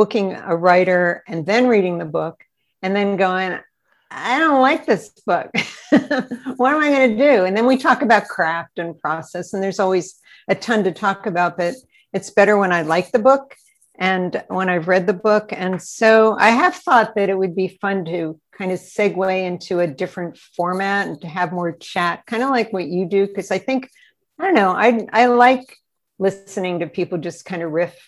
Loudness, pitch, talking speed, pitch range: -18 LUFS, 195 Hz, 205 wpm, 180-230 Hz